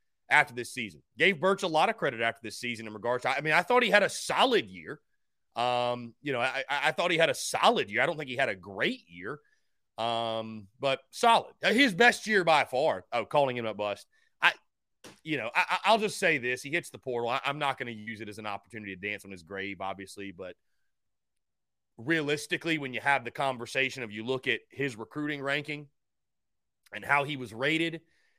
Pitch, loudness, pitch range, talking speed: 130 Hz, -28 LUFS, 115-165 Hz, 220 wpm